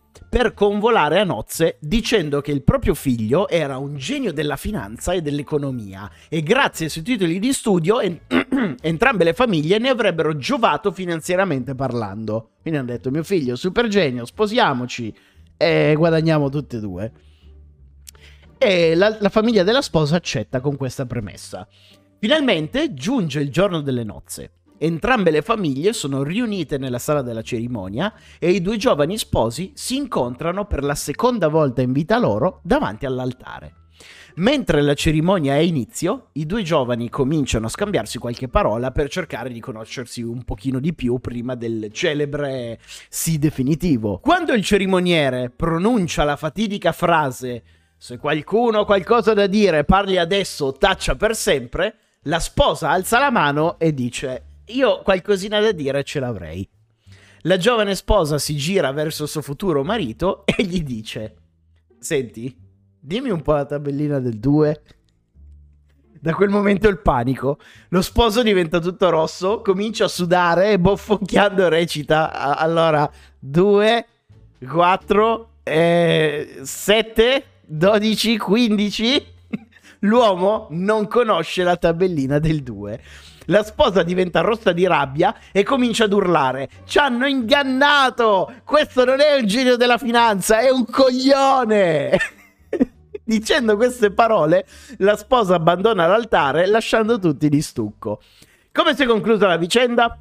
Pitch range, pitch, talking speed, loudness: 130-210 Hz, 165 Hz, 140 wpm, -19 LUFS